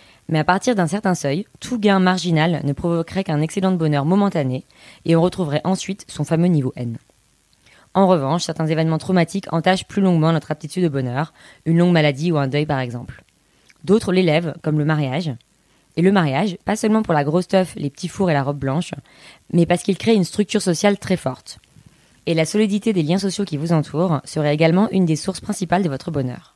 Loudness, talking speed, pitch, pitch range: -19 LUFS, 210 wpm, 170 Hz, 150-190 Hz